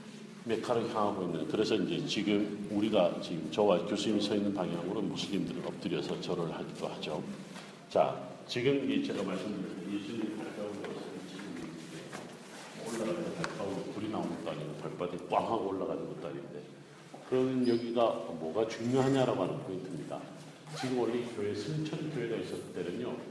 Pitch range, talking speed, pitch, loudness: 105-130 Hz, 360 characters per minute, 115 Hz, -34 LUFS